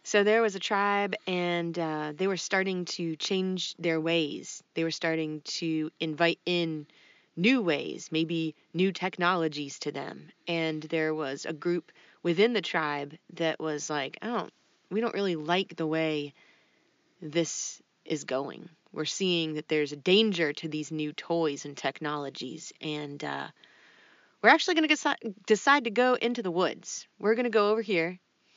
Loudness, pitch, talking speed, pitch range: -29 LUFS, 165 Hz, 165 wpm, 155-190 Hz